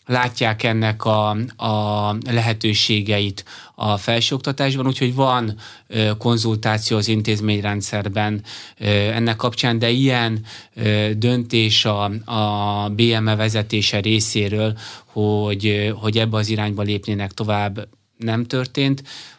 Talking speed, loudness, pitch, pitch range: 95 wpm, -19 LUFS, 110 Hz, 105-115 Hz